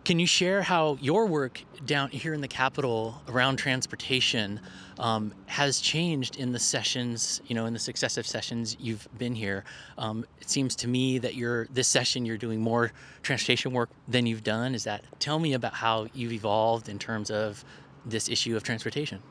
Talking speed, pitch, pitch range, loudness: 185 wpm, 120 Hz, 115-135 Hz, -28 LUFS